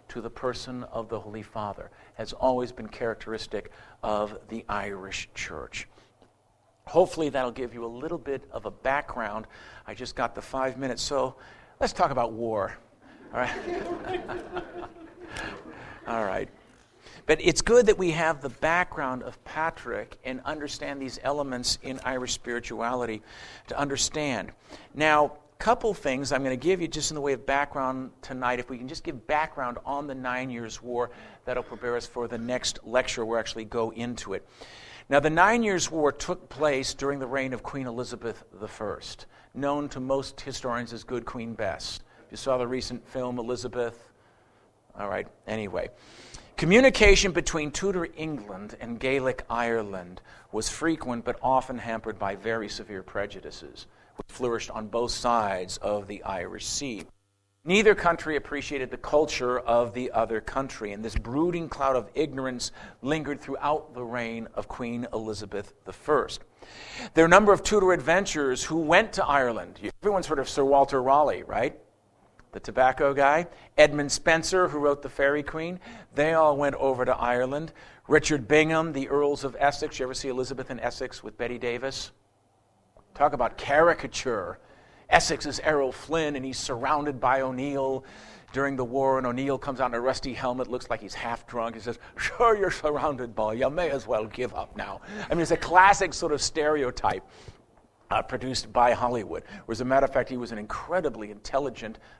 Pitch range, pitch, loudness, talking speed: 120-150 Hz, 130 Hz, -27 LUFS, 170 wpm